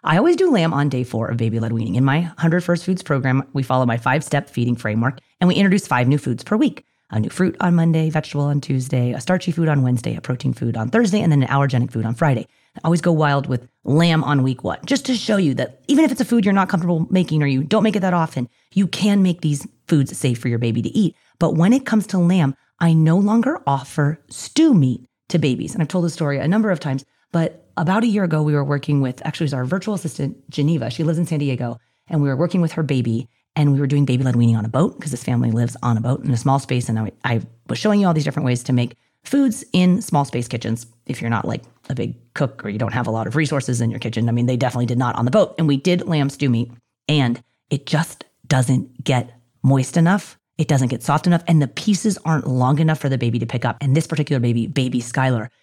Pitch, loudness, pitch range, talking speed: 140 Hz, -19 LUFS, 125-170 Hz, 270 wpm